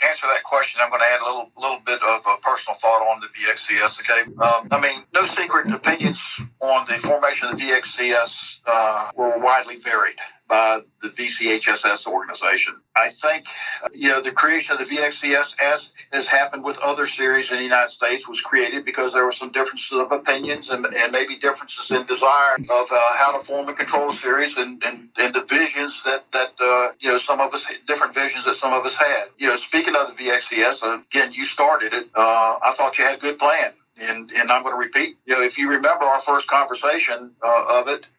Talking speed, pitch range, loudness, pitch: 215 wpm, 120-145 Hz, -19 LUFS, 130 Hz